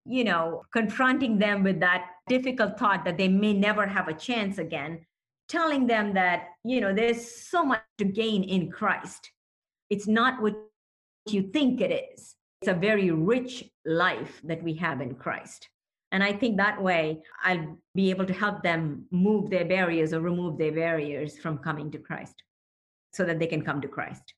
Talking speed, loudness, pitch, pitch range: 180 wpm, -27 LUFS, 190 Hz, 165-215 Hz